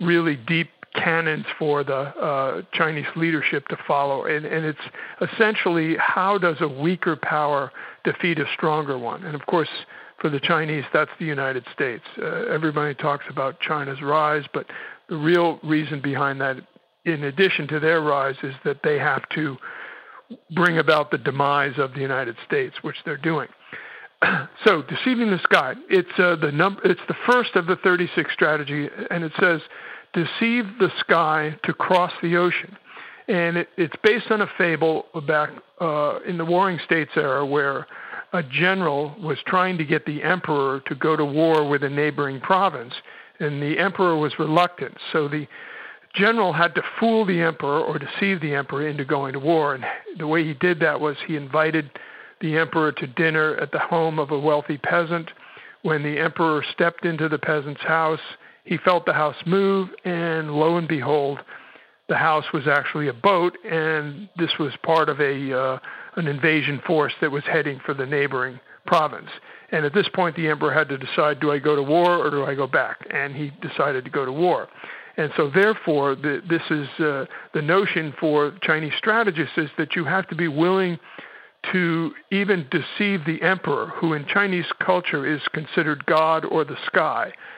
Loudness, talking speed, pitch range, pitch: -22 LUFS, 180 wpm, 150-175 Hz, 160 Hz